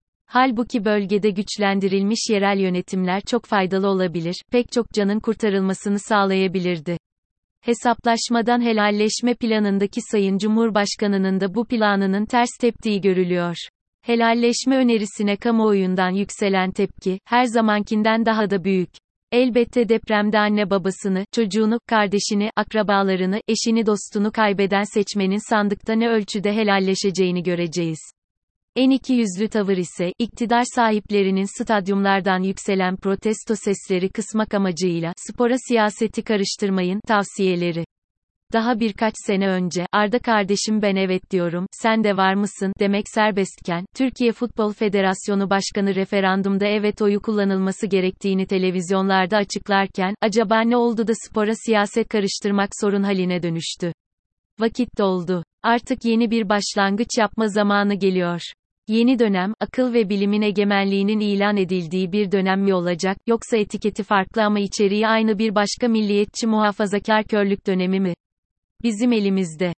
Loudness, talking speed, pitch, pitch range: -20 LUFS, 120 wpm, 205 Hz, 190-220 Hz